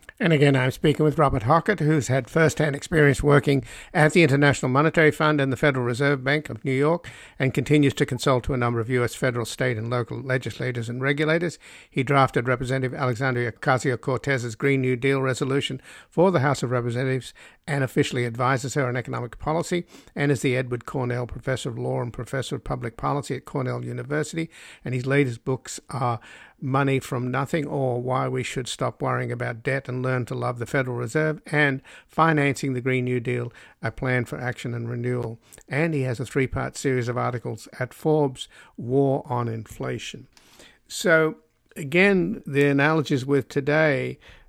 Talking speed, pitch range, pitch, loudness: 180 wpm, 125-145 Hz, 135 Hz, -24 LUFS